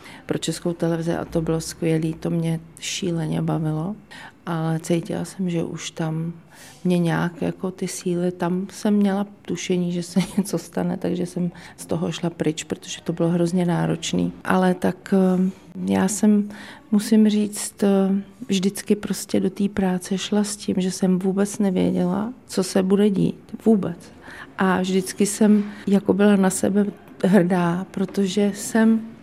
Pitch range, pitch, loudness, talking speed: 170-200 Hz, 185 Hz, -22 LUFS, 150 wpm